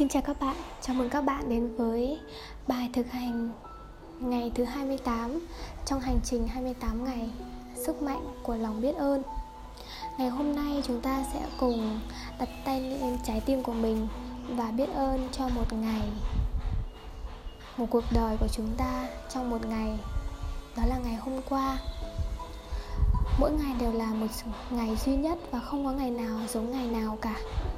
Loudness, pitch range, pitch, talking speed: -32 LUFS, 225-270 Hz, 240 Hz, 170 wpm